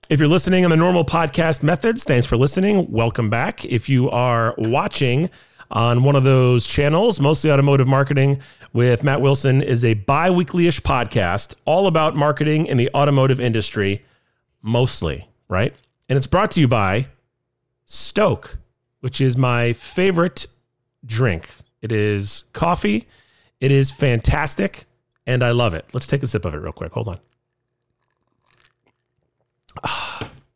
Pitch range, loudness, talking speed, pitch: 120-150 Hz, -18 LUFS, 145 wpm, 130 Hz